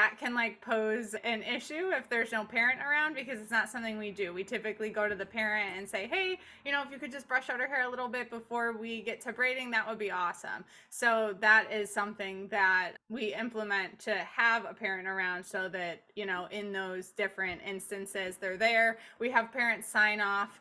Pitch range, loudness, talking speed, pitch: 200-235 Hz, -32 LUFS, 215 wpm, 220 Hz